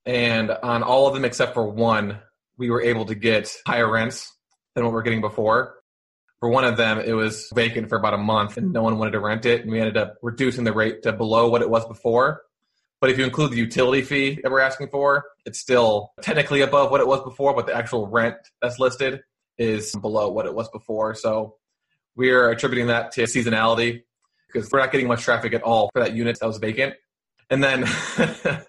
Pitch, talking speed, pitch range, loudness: 115 Hz, 220 wpm, 110-130 Hz, -21 LUFS